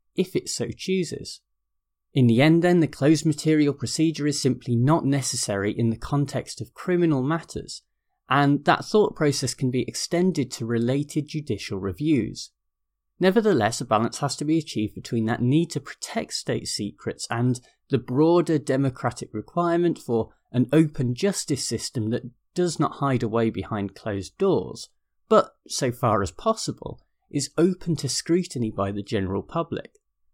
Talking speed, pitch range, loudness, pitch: 155 wpm, 115-160 Hz, -24 LUFS, 135 Hz